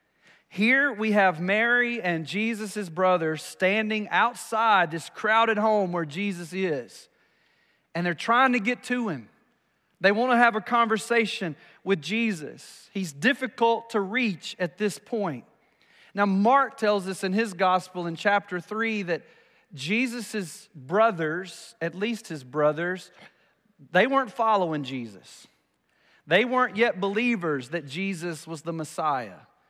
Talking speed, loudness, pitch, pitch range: 135 wpm, -25 LUFS, 205 Hz, 175-230 Hz